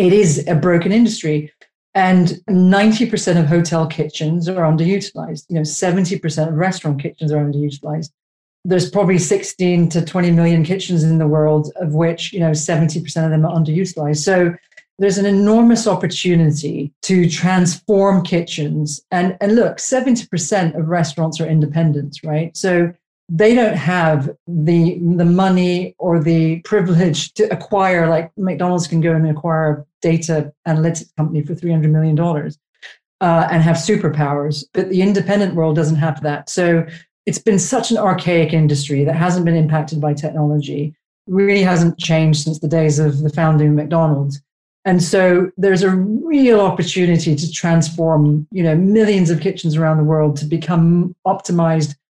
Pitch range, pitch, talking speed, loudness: 155-185 Hz, 170 Hz, 155 wpm, -16 LUFS